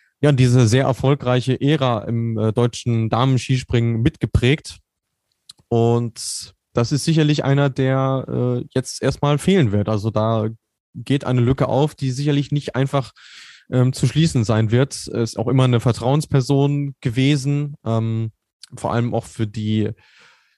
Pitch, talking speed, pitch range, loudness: 125 Hz, 140 wpm, 115-140 Hz, -19 LUFS